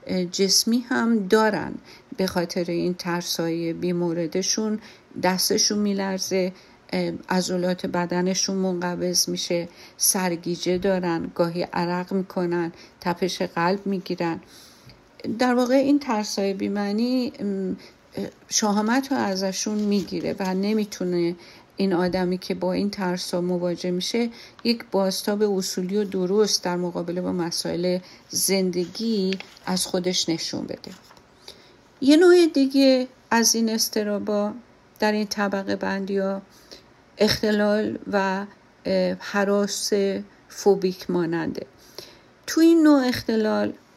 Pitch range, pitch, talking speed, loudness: 180-210 Hz, 195 Hz, 105 wpm, -23 LUFS